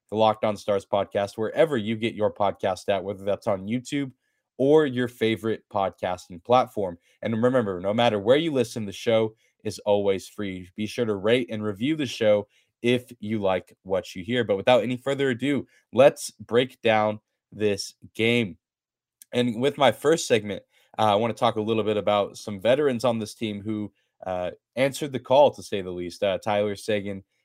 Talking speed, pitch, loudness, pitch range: 190 wpm, 110 Hz, -25 LUFS, 100-120 Hz